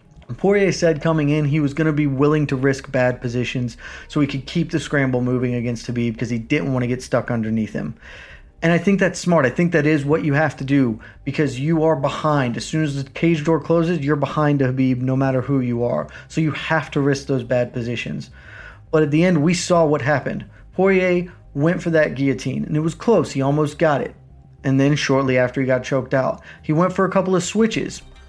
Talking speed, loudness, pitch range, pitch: 230 wpm, -20 LUFS, 130-160 Hz, 145 Hz